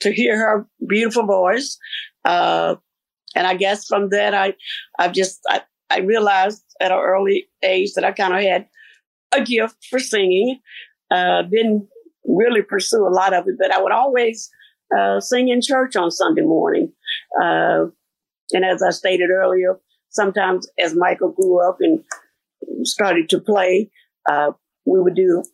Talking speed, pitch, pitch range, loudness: 160 wpm, 200 Hz, 185-250 Hz, -18 LUFS